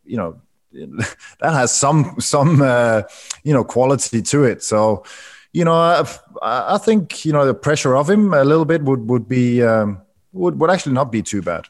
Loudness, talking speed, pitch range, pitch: -16 LUFS, 195 wpm, 115-160 Hz, 135 Hz